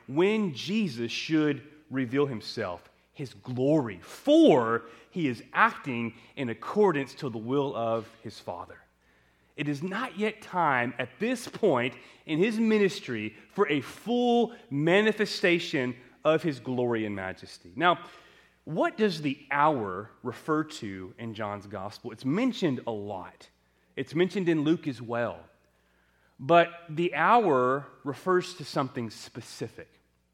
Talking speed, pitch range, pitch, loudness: 130 wpm, 115-175 Hz, 135 Hz, -28 LUFS